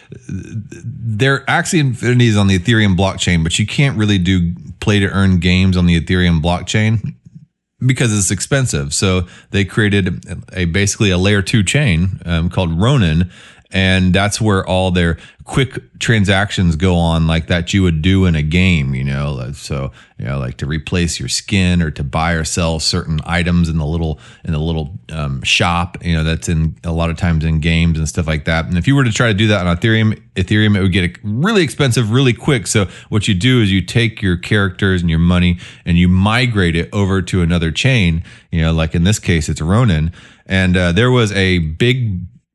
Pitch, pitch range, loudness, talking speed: 95 Hz, 85-110 Hz, -15 LUFS, 200 wpm